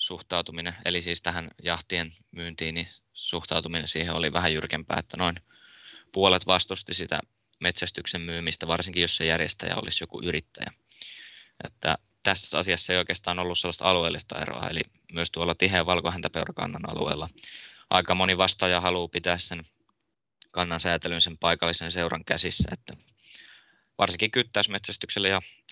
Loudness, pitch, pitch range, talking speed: -26 LUFS, 85 Hz, 85-90 Hz, 135 wpm